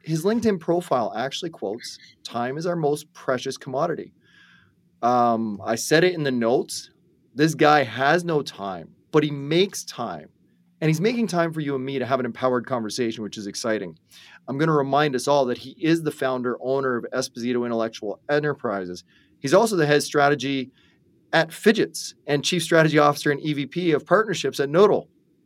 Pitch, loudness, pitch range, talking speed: 140 Hz, -23 LUFS, 125-160 Hz, 180 wpm